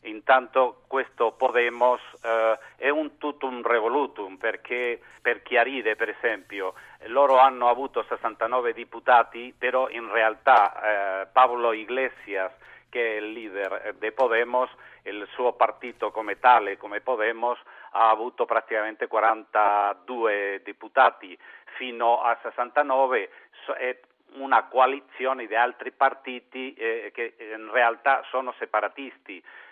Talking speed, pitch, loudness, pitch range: 115 wpm, 125 Hz, -24 LUFS, 115-130 Hz